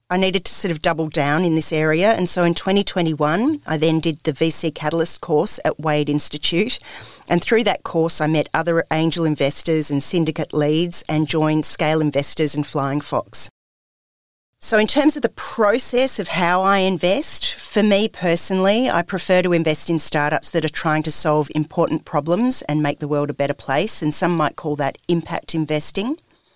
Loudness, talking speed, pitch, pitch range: -19 LUFS, 190 wpm, 160 Hz, 150-180 Hz